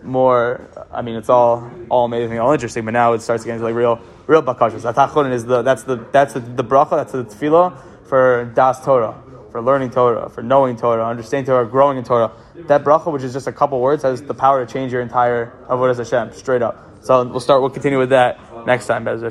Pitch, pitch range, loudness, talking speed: 125 Hz, 120-135 Hz, -17 LUFS, 220 wpm